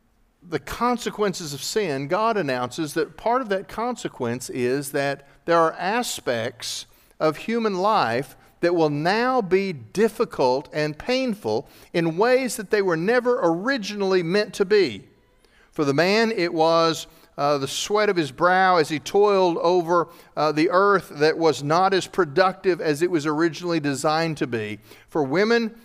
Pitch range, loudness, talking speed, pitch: 155-210 Hz, -22 LUFS, 160 wpm, 170 Hz